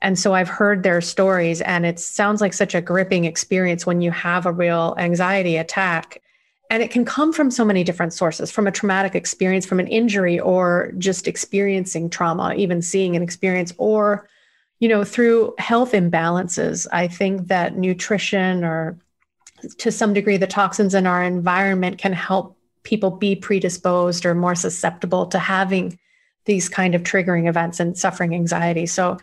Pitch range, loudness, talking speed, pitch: 175-200 Hz, -19 LUFS, 170 wpm, 185 Hz